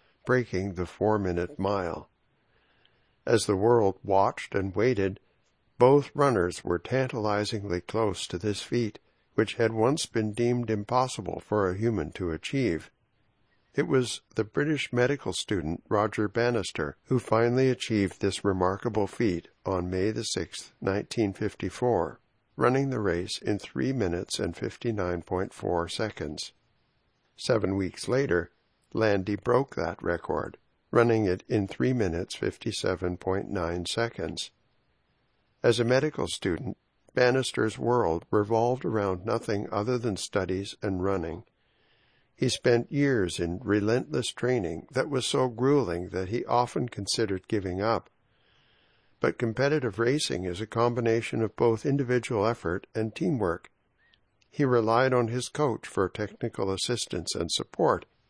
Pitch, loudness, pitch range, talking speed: 110 Hz, -28 LUFS, 95-120 Hz, 125 wpm